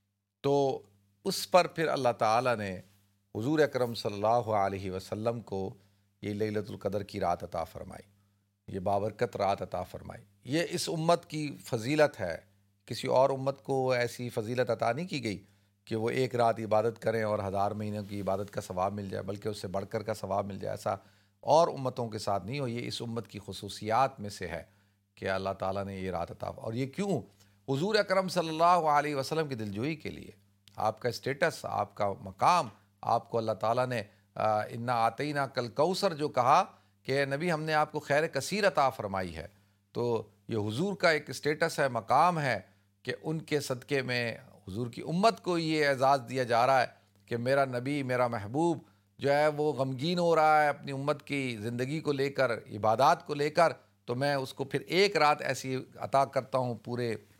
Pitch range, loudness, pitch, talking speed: 100-140 Hz, -31 LUFS, 120 Hz, 200 wpm